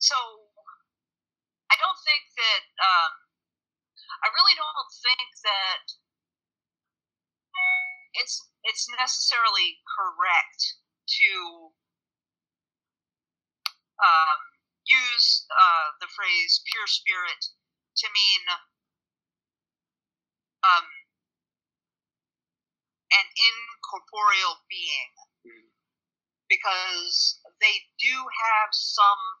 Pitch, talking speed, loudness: 255 Hz, 70 wpm, -22 LUFS